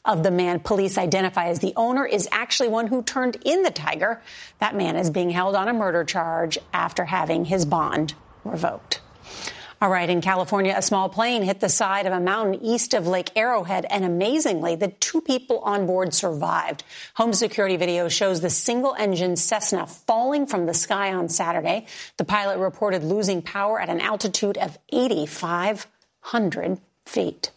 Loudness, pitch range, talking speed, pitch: -23 LUFS, 180-215 Hz, 175 wpm, 195 Hz